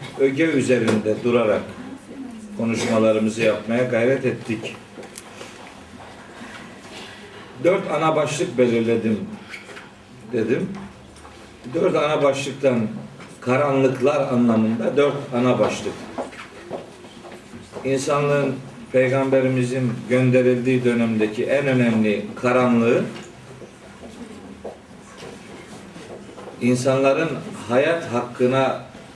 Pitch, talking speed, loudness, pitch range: 130 Hz, 60 wpm, -20 LUFS, 115-140 Hz